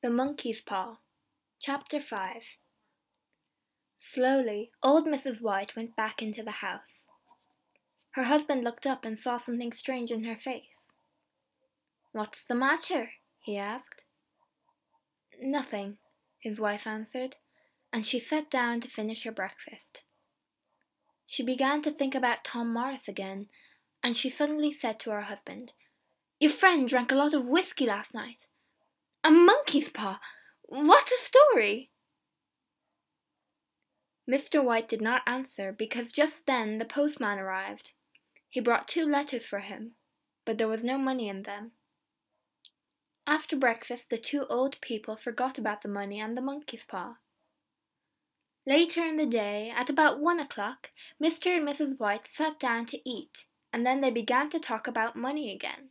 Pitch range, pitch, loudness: 225-290 Hz, 250 Hz, -29 LUFS